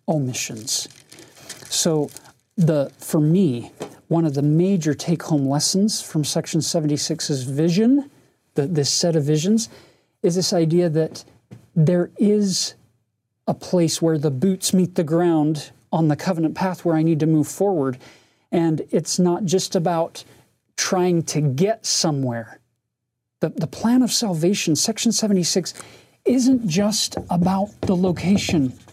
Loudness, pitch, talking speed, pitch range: -20 LUFS, 165 Hz, 135 wpm, 150-190 Hz